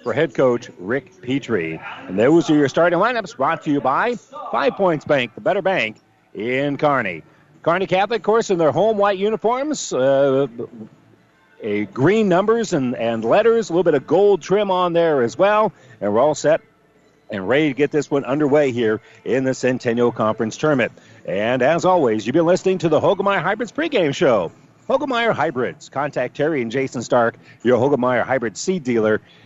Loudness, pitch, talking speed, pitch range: -19 LUFS, 155 Hz, 185 wpm, 130-195 Hz